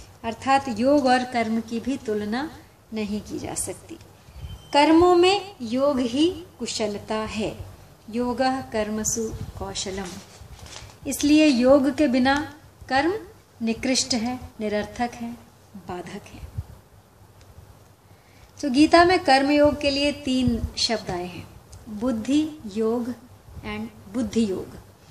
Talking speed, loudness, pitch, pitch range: 110 wpm, -23 LUFS, 235 Hz, 195-275 Hz